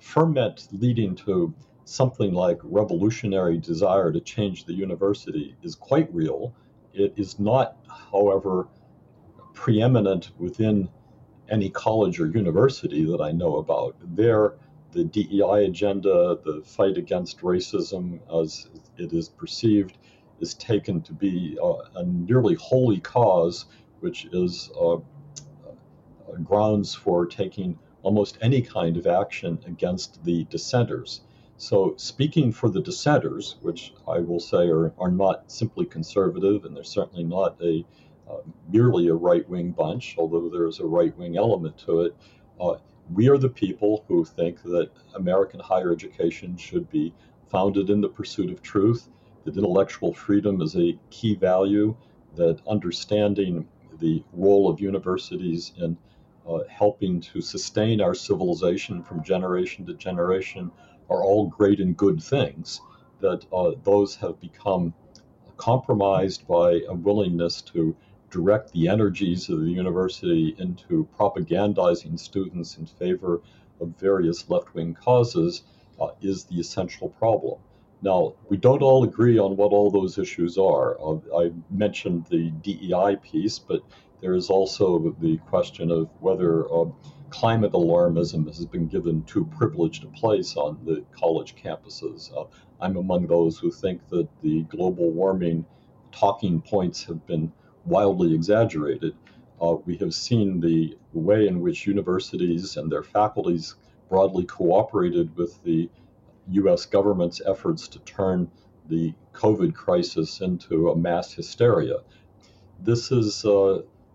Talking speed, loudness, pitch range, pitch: 140 wpm, -24 LUFS, 85-110 Hz, 95 Hz